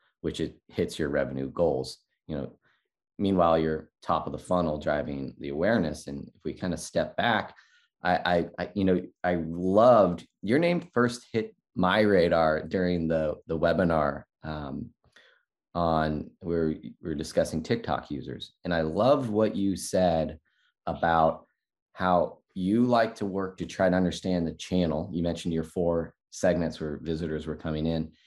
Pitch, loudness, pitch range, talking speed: 85 Hz, -27 LUFS, 80-95 Hz, 165 wpm